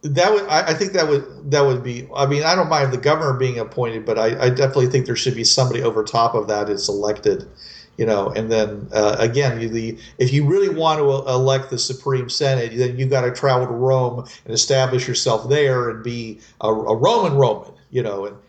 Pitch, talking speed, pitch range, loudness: 125 Hz, 225 wpm, 115-140 Hz, -19 LUFS